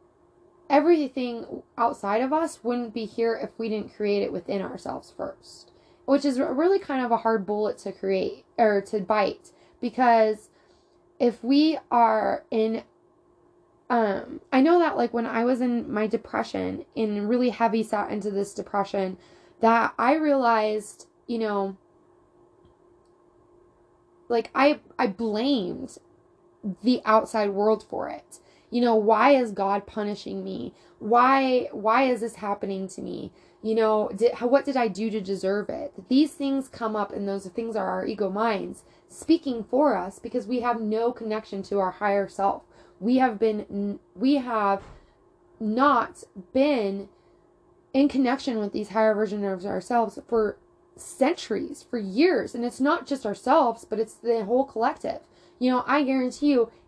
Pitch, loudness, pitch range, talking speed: 235 Hz, -25 LUFS, 215-285 Hz, 155 wpm